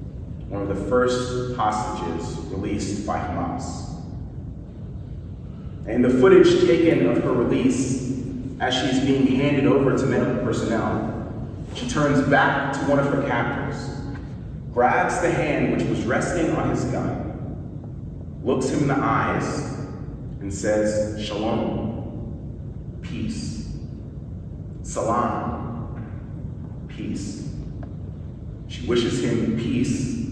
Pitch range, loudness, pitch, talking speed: 110-135 Hz, -23 LUFS, 125 Hz, 110 wpm